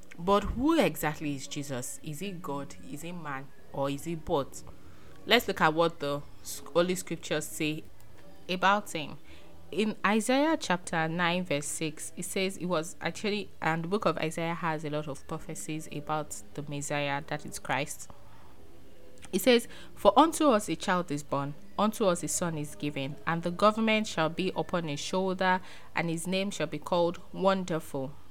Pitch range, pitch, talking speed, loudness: 145-185 Hz, 160 Hz, 175 wpm, -30 LUFS